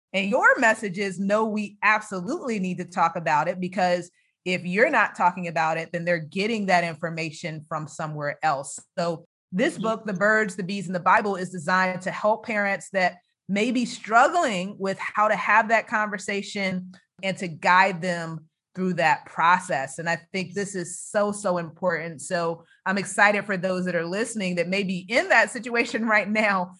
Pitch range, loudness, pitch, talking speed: 175-210 Hz, -24 LUFS, 185 Hz, 185 wpm